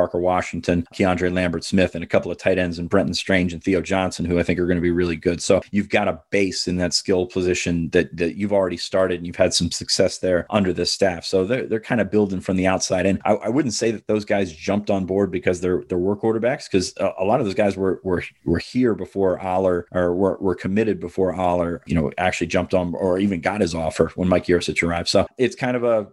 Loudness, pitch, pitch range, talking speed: -21 LUFS, 90 Hz, 90-100 Hz, 255 wpm